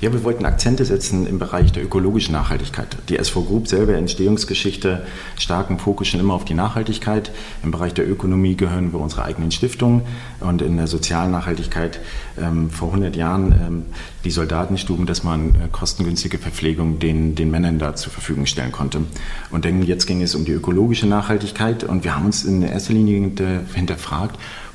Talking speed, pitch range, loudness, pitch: 180 wpm, 85-100 Hz, -20 LUFS, 90 Hz